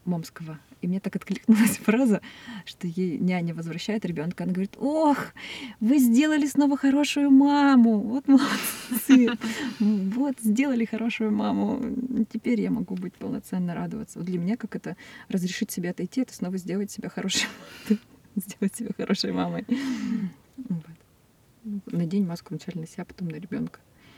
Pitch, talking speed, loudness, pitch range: 215 Hz, 135 wpm, -25 LUFS, 185-245 Hz